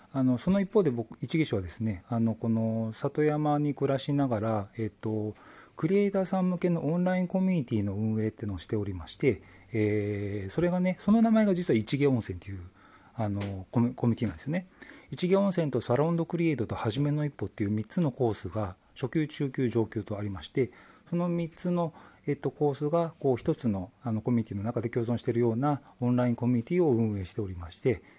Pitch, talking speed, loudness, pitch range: 120 Hz, 415 characters per minute, -29 LUFS, 110-155 Hz